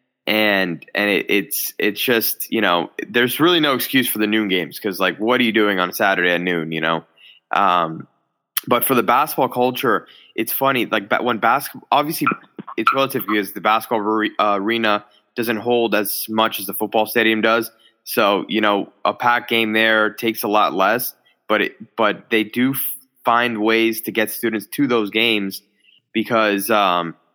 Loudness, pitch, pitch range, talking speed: -18 LUFS, 110 Hz, 105-115 Hz, 185 wpm